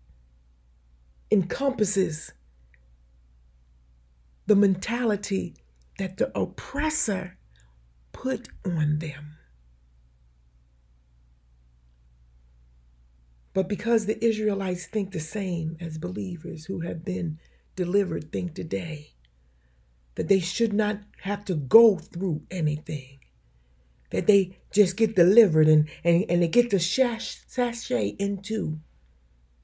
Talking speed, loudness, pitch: 95 wpm, -26 LUFS, 155 Hz